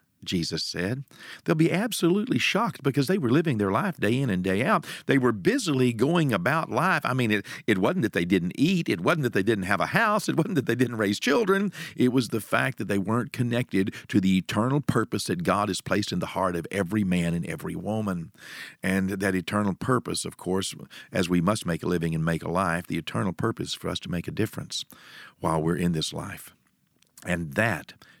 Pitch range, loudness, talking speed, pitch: 95-140 Hz, -26 LUFS, 220 wpm, 110 Hz